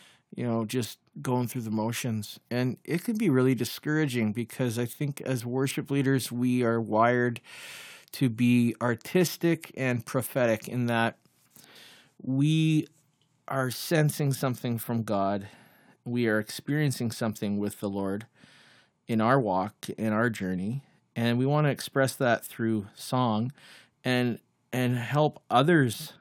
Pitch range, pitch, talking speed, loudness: 115-140 Hz, 125 Hz, 135 wpm, -28 LUFS